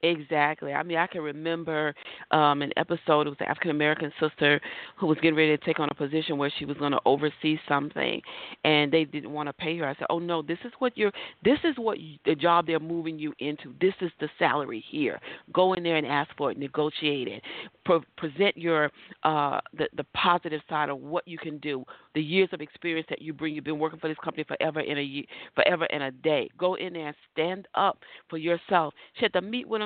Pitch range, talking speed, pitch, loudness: 150-170 Hz, 235 wpm, 160 Hz, -27 LUFS